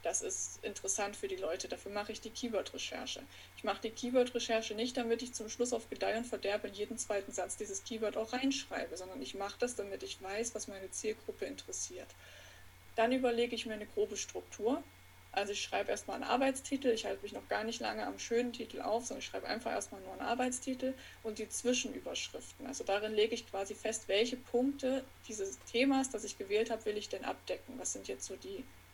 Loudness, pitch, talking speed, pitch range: -38 LUFS, 230 Hz, 210 wpm, 215-250 Hz